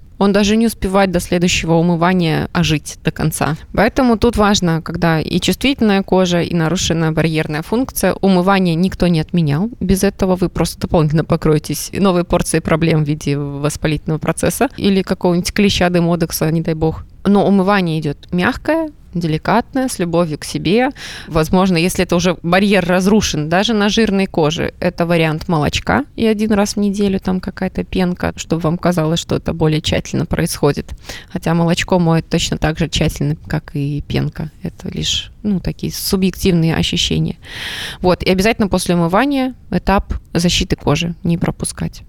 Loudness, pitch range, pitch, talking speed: -16 LUFS, 160-195 Hz, 175 Hz, 155 wpm